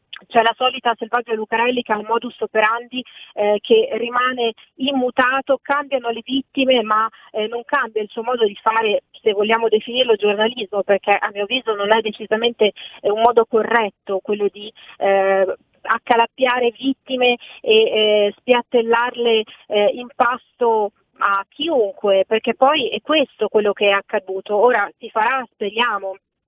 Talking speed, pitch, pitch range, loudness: 145 wpm, 225 Hz, 210-245 Hz, -18 LUFS